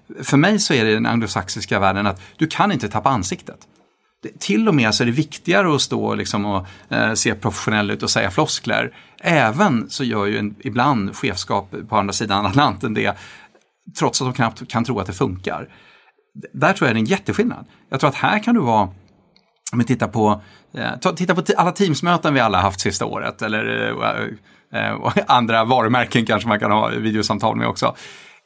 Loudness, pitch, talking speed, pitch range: -19 LUFS, 120 Hz, 200 wpm, 105-155 Hz